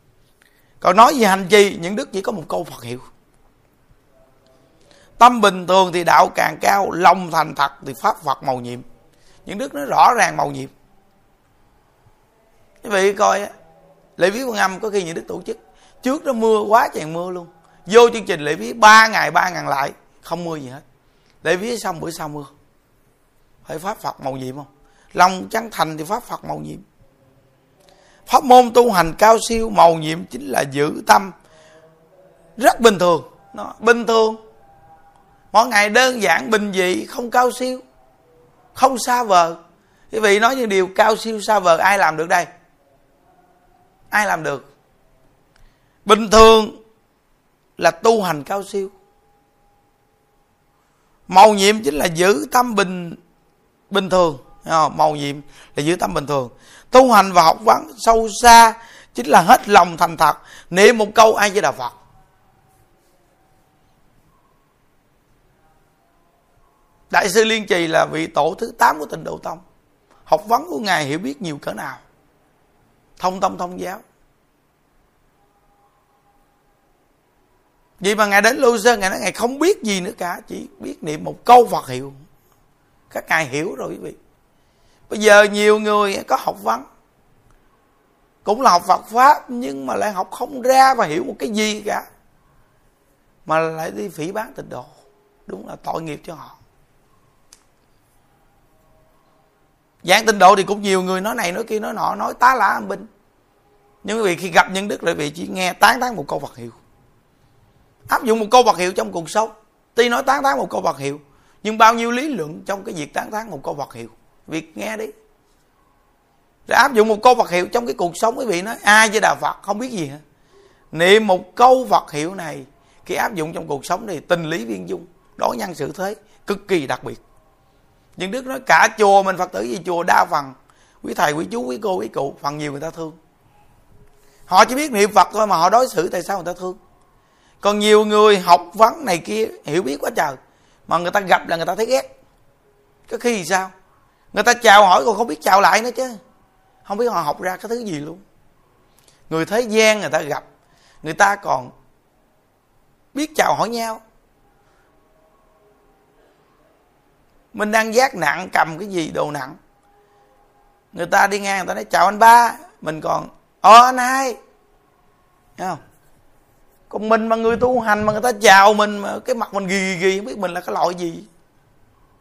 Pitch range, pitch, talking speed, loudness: 155-220 Hz, 190 Hz, 185 wpm, -16 LUFS